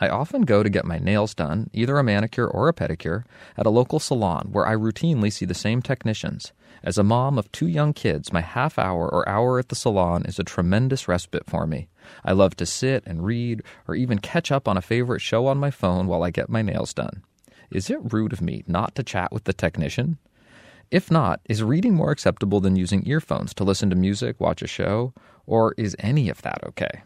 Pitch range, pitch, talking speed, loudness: 100-130 Hz, 110 Hz, 225 wpm, -23 LUFS